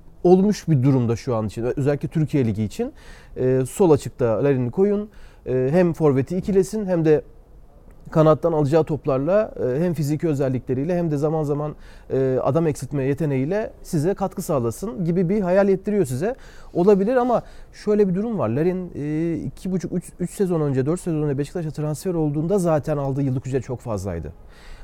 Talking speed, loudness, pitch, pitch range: 155 wpm, -22 LUFS, 155 Hz, 135-185 Hz